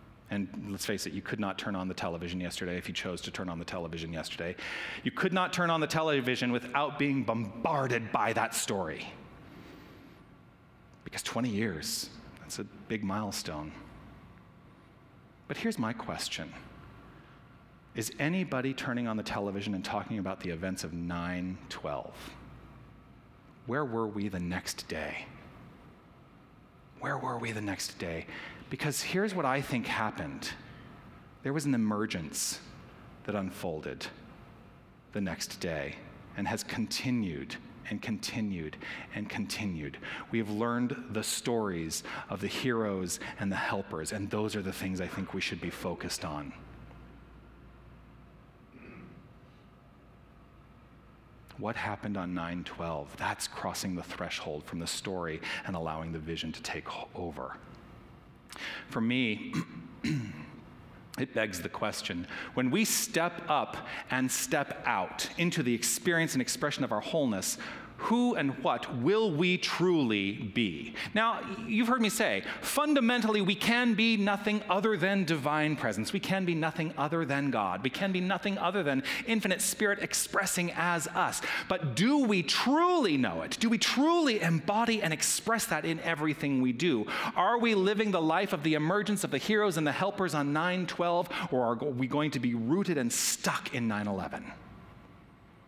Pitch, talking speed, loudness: 135 Hz, 150 wpm, -32 LUFS